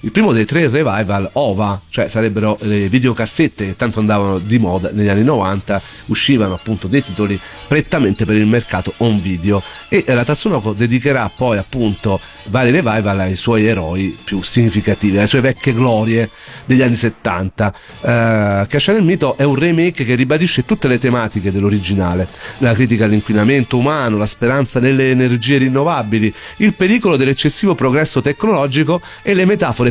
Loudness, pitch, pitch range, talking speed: -14 LUFS, 115 Hz, 105-135 Hz, 160 wpm